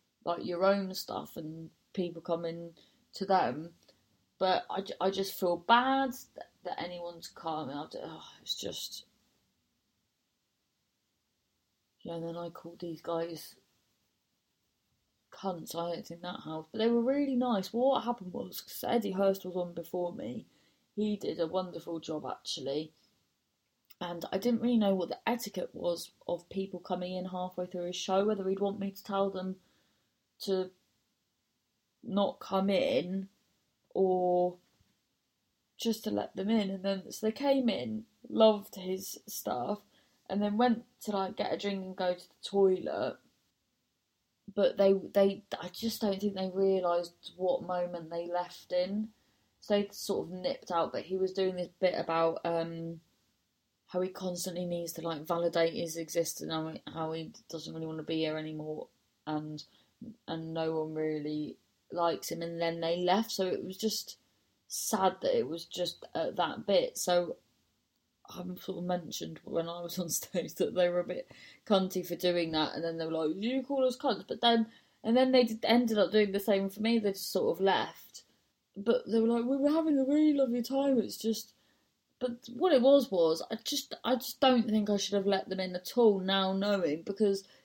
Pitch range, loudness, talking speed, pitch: 170-220 Hz, -32 LUFS, 185 wpm, 185 Hz